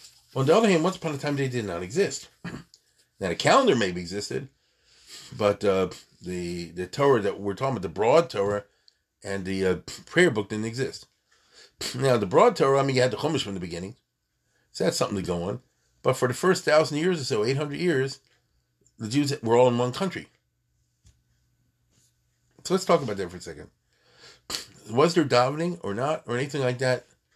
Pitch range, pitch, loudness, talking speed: 100-145 Hz, 125 Hz, -25 LUFS, 195 wpm